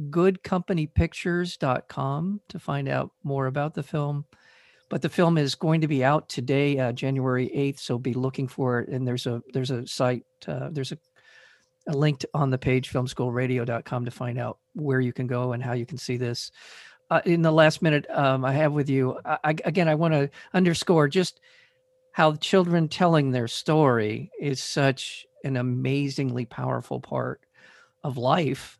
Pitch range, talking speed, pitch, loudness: 130-160 Hz, 175 wpm, 140 Hz, -25 LUFS